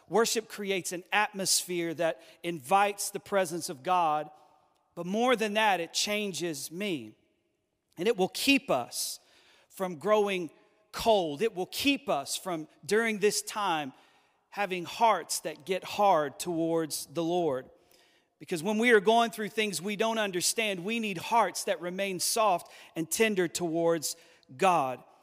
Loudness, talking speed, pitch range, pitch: -29 LUFS, 145 wpm, 170-210 Hz, 185 Hz